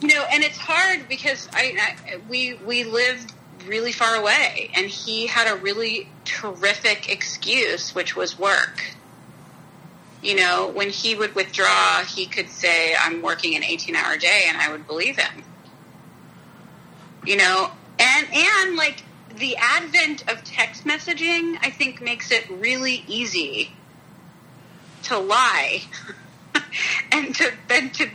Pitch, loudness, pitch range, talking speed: 240 Hz, -20 LUFS, 210-300 Hz, 140 wpm